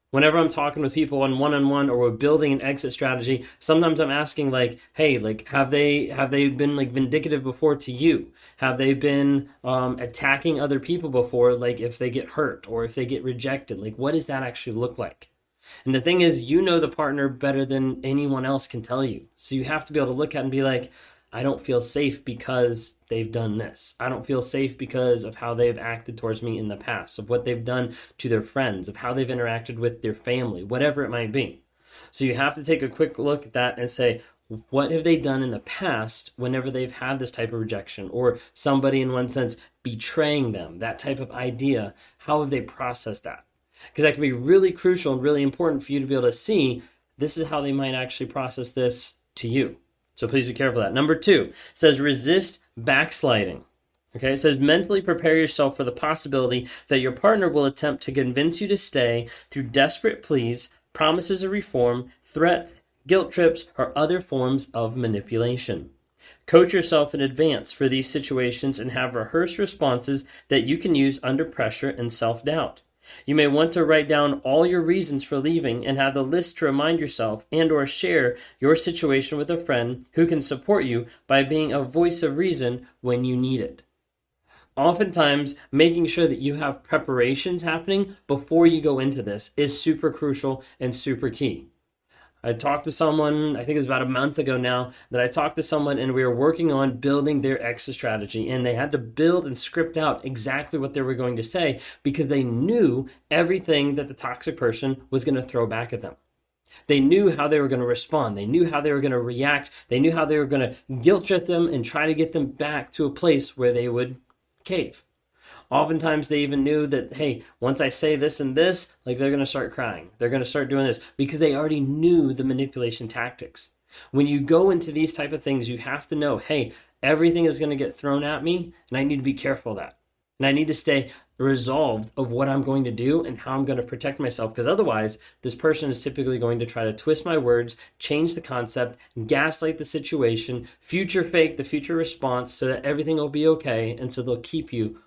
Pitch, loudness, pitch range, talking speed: 135 Hz, -23 LUFS, 125-155 Hz, 215 wpm